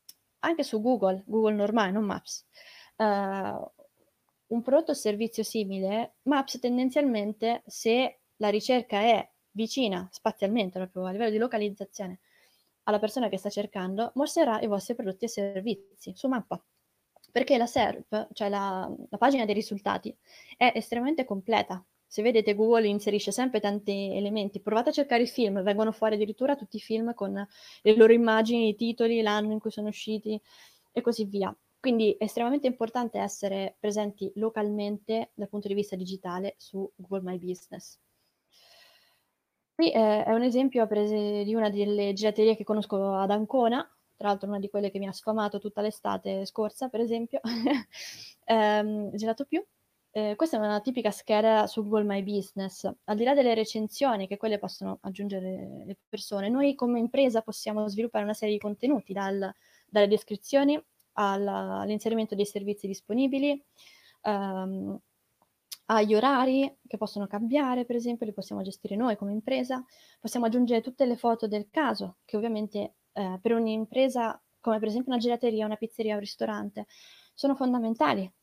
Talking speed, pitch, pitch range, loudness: 160 wpm, 215 Hz, 205-235 Hz, -28 LUFS